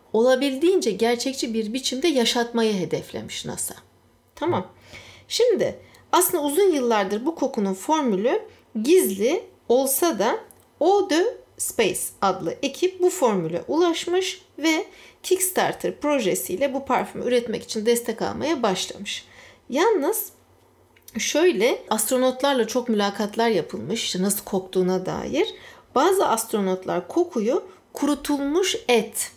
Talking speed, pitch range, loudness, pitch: 100 wpm, 225-365 Hz, -23 LUFS, 275 Hz